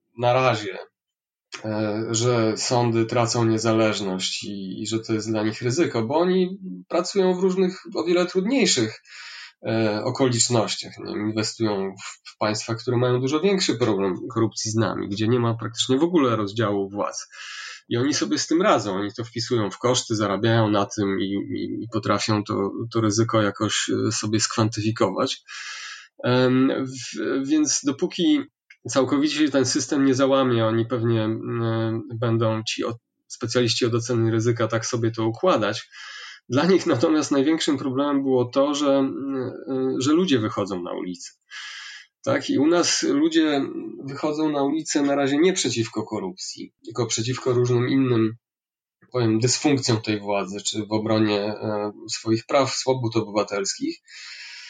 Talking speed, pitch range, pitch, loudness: 150 wpm, 110-140 Hz, 120 Hz, -23 LUFS